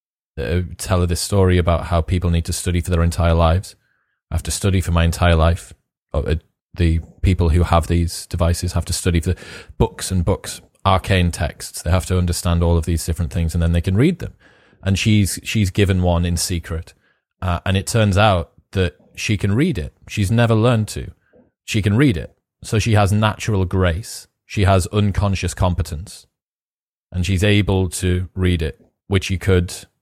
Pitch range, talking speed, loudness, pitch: 85-100 Hz, 195 wpm, -19 LUFS, 90 Hz